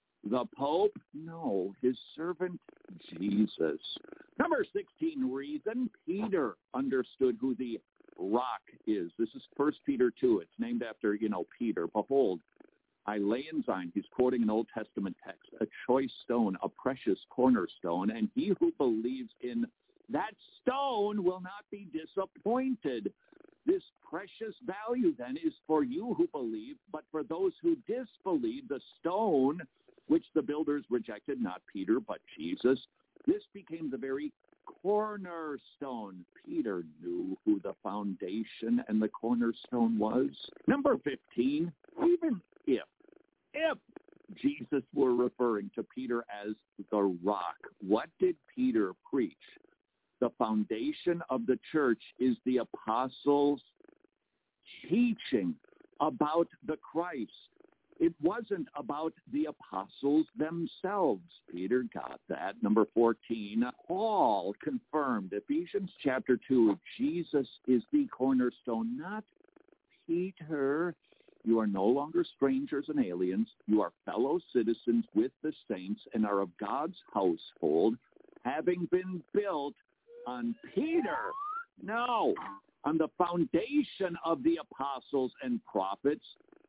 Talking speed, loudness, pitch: 120 wpm, -33 LUFS, 185 Hz